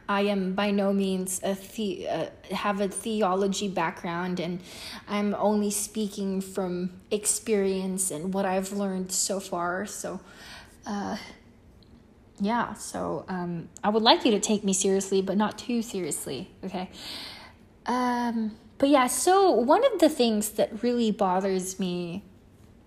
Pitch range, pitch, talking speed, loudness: 190-215 Hz, 200 Hz, 140 wpm, -27 LUFS